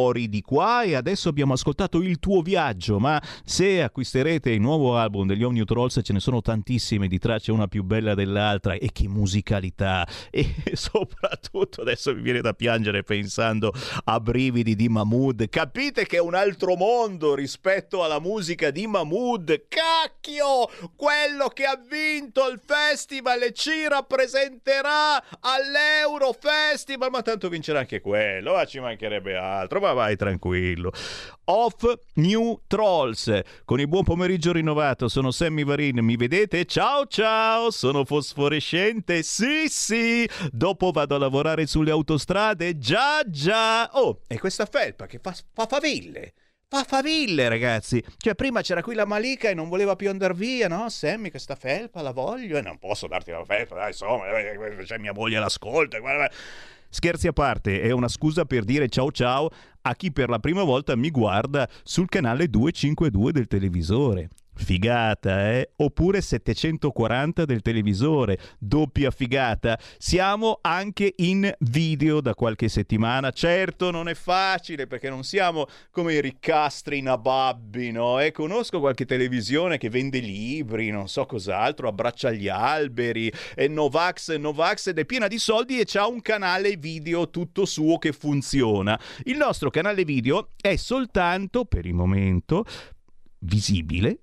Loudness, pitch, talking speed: -24 LUFS, 155 Hz, 150 wpm